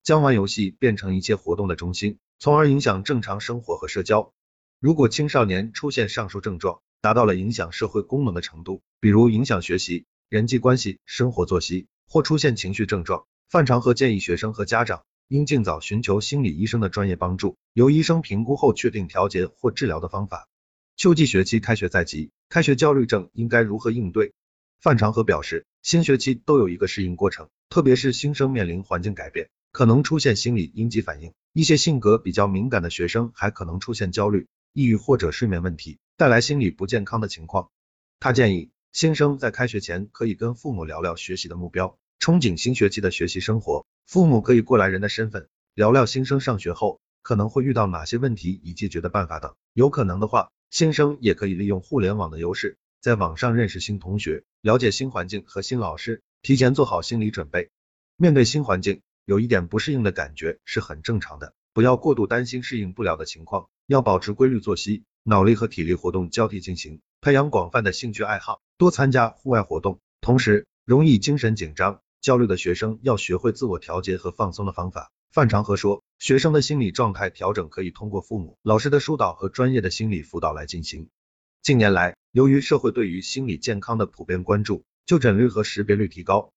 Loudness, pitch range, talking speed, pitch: -22 LUFS, 95-125 Hz, 320 characters per minute, 110 Hz